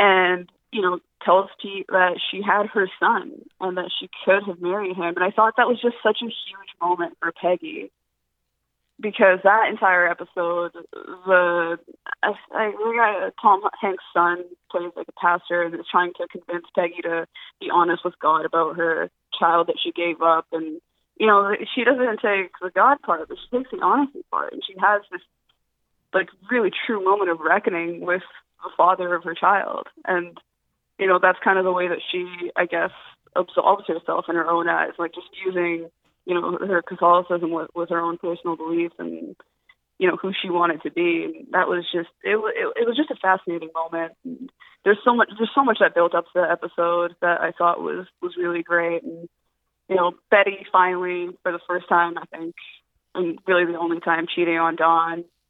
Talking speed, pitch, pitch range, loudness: 195 wpm, 180 Hz, 170-200 Hz, -22 LUFS